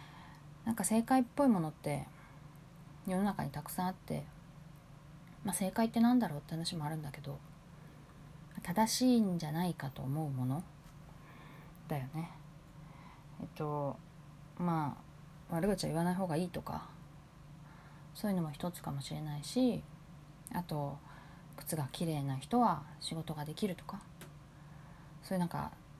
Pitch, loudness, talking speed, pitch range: 155 Hz, -36 LUFS, 270 characters per minute, 150-175 Hz